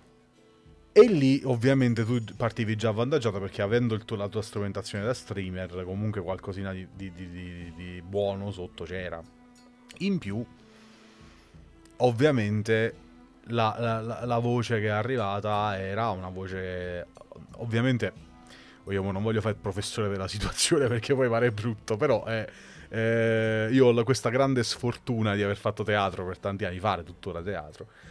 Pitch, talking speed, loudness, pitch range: 105 Hz, 150 wpm, -28 LUFS, 95-120 Hz